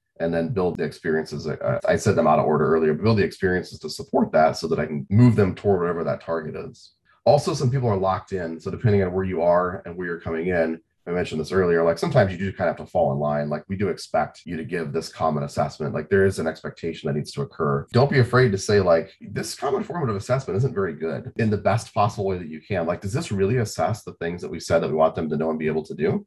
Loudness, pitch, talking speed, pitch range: -23 LUFS, 95 Hz, 280 wpm, 80-120 Hz